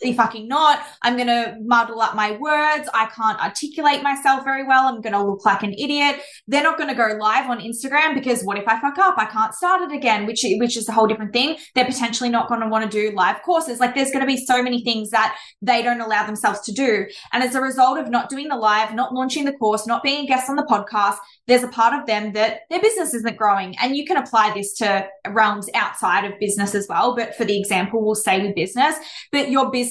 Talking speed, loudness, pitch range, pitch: 255 wpm, -19 LUFS, 215-270 Hz, 235 Hz